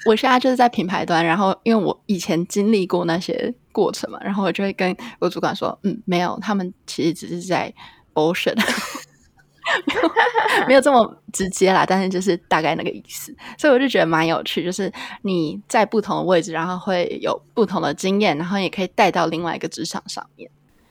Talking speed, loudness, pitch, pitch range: 315 characters per minute, -20 LUFS, 190 Hz, 175-225 Hz